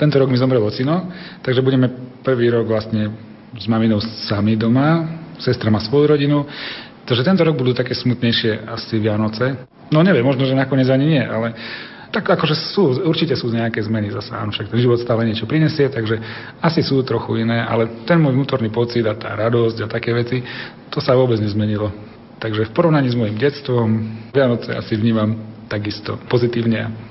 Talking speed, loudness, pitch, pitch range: 175 wpm, -18 LUFS, 120 Hz, 110-135 Hz